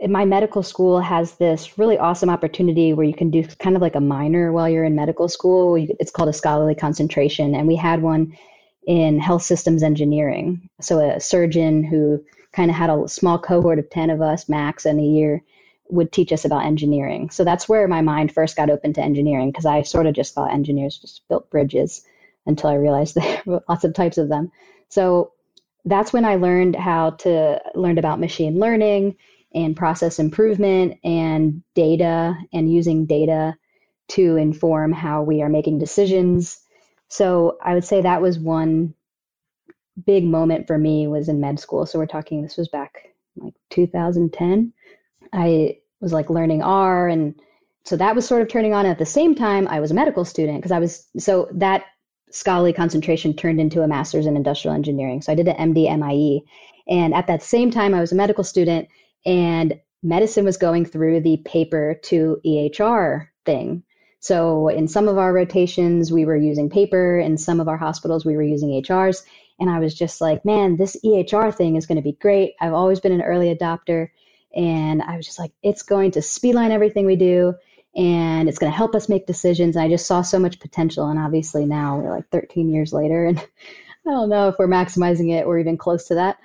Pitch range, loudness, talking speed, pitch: 155-185 Hz, -19 LUFS, 200 wpm, 170 Hz